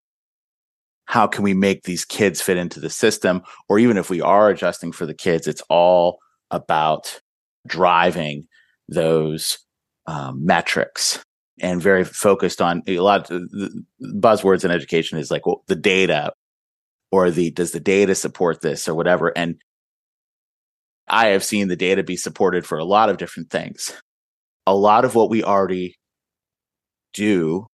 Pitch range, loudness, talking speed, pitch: 85-95 Hz, -19 LUFS, 155 wpm, 90 Hz